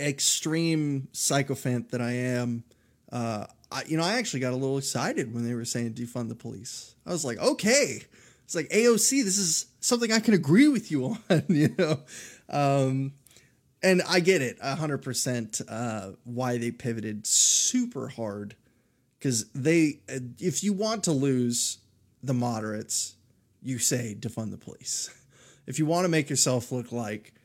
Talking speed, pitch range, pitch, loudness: 165 wpm, 120-155 Hz, 130 Hz, -26 LUFS